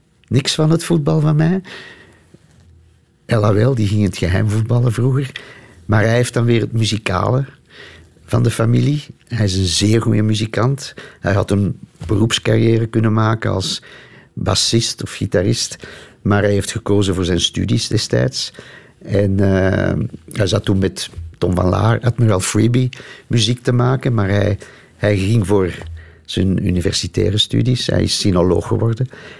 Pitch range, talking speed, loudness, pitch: 95-120 Hz, 150 wpm, -17 LUFS, 110 Hz